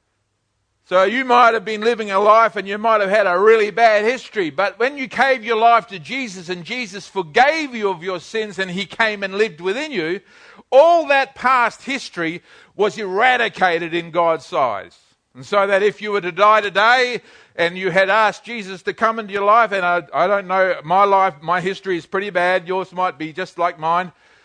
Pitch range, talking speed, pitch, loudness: 185-225 Hz, 210 wpm, 200 Hz, -17 LUFS